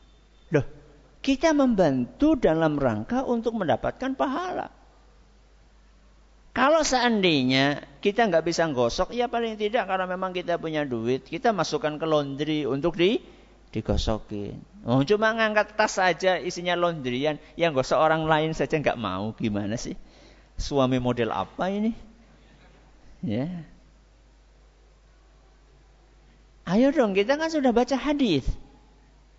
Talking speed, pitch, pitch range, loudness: 115 wpm, 170 Hz, 140-225 Hz, -25 LUFS